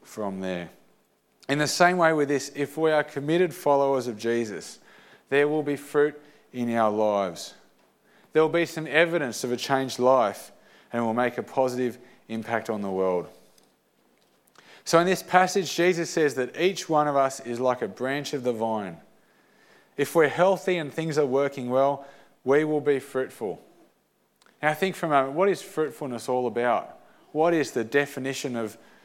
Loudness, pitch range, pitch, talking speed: -25 LUFS, 120-155 Hz, 140 Hz, 180 wpm